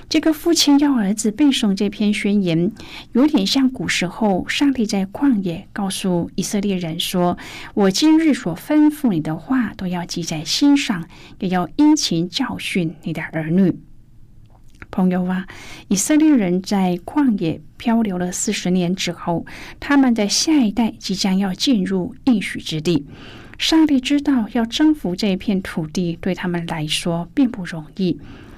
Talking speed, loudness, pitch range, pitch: 230 characters per minute, -19 LUFS, 175-255 Hz, 195 Hz